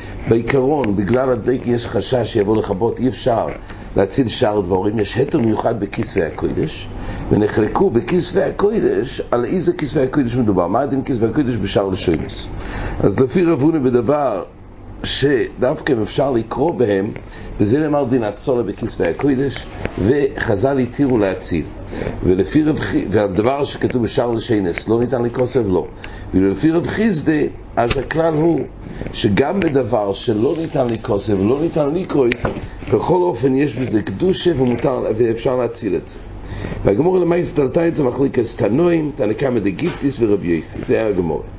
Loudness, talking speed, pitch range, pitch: -18 LUFS, 145 wpm, 105-145 Hz, 125 Hz